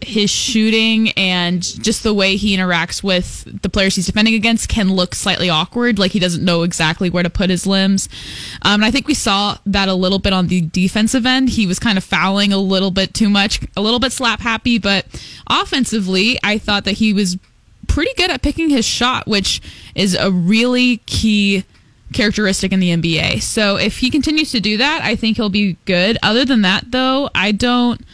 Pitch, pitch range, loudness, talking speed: 205 Hz, 190-230 Hz, -15 LUFS, 205 wpm